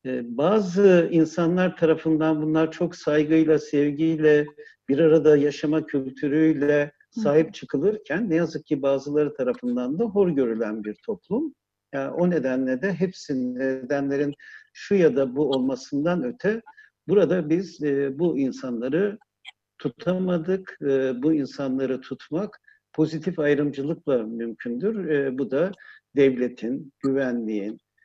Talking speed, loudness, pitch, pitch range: 105 wpm, -24 LUFS, 155 Hz, 140-190 Hz